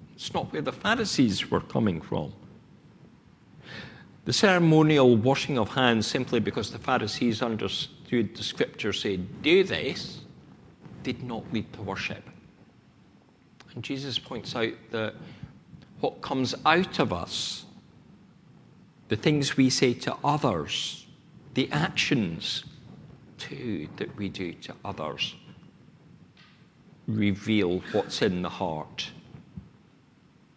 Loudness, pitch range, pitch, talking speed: -27 LUFS, 115-155 Hz, 135 Hz, 110 wpm